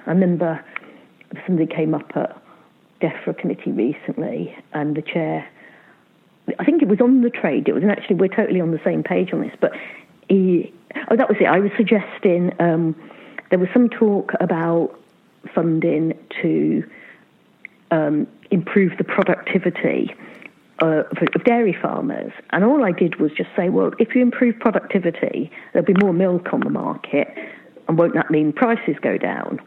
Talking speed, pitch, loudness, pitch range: 170 wpm, 185 Hz, -19 LUFS, 165-220 Hz